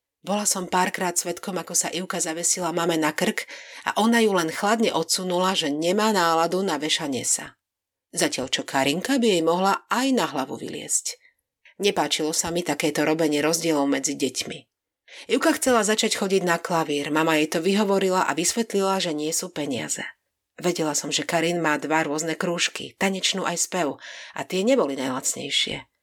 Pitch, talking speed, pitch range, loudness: 170 Hz, 165 wpm, 160-195 Hz, -23 LUFS